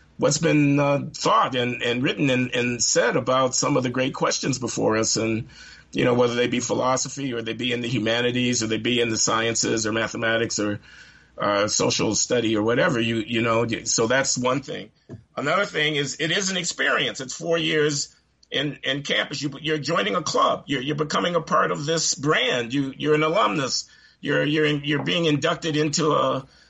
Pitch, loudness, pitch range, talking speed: 130 Hz, -22 LUFS, 115-150 Hz, 200 wpm